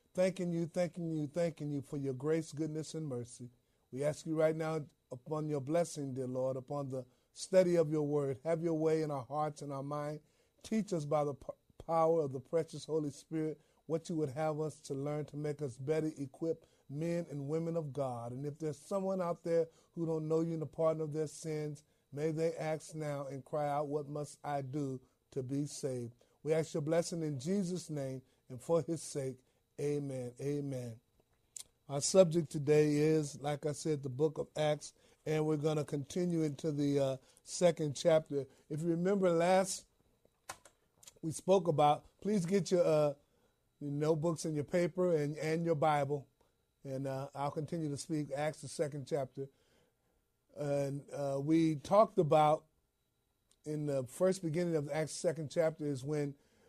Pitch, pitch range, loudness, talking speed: 150 Hz, 140-160 Hz, -36 LUFS, 185 wpm